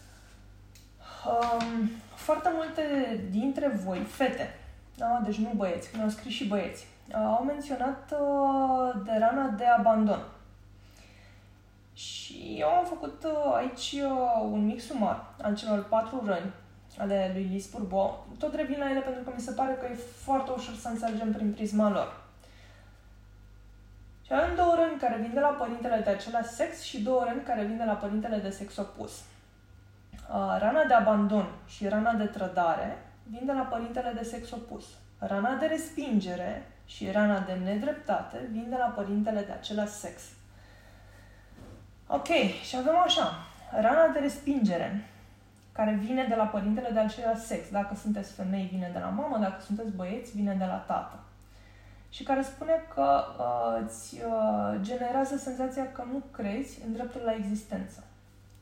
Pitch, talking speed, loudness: 215 Hz, 155 wpm, -30 LUFS